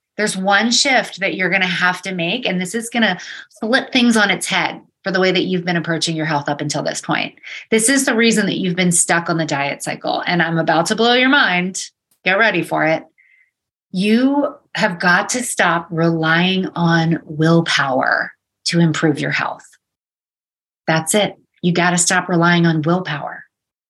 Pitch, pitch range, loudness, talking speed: 180 Hz, 165-215 Hz, -16 LUFS, 195 wpm